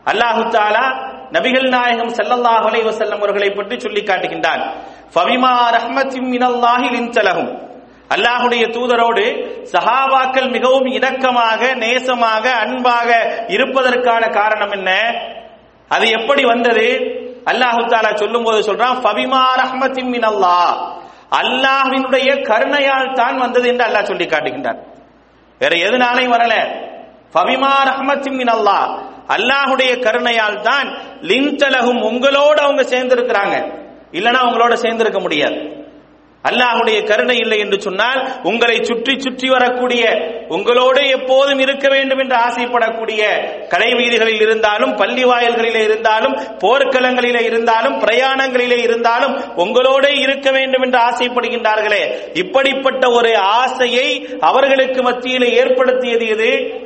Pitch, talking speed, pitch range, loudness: 245 Hz, 110 wpm, 225-265 Hz, -14 LUFS